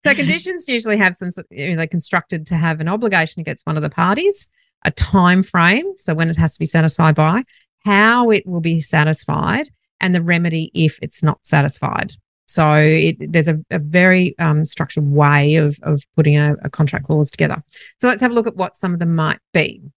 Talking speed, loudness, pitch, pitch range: 210 wpm, -16 LUFS, 165 Hz, 155-190 Hz